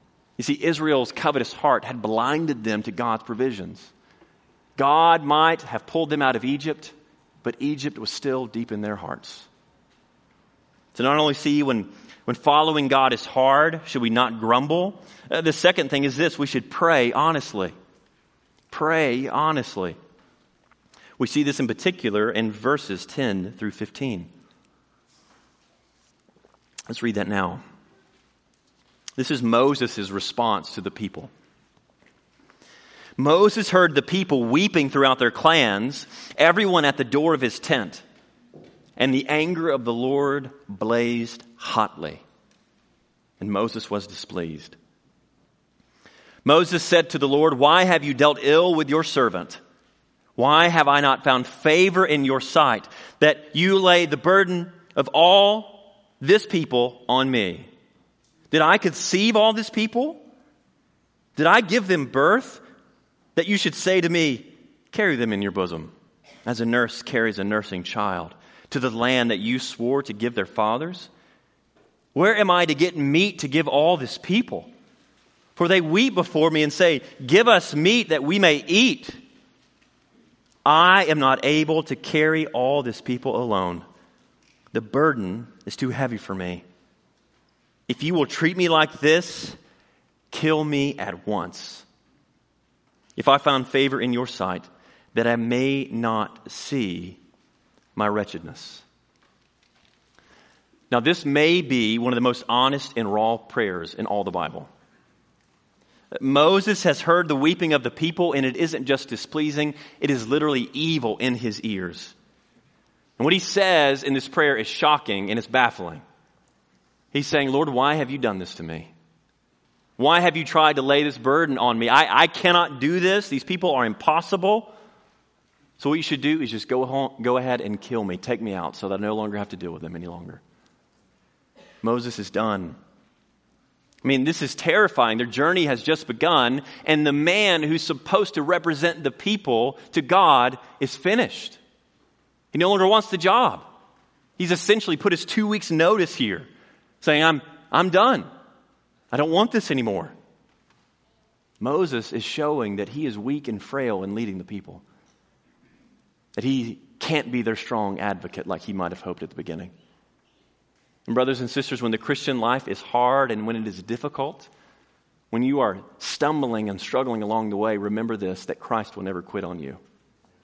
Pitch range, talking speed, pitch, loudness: 115-165 Hz, 160 wpm, 140 Hz, -21 LUFS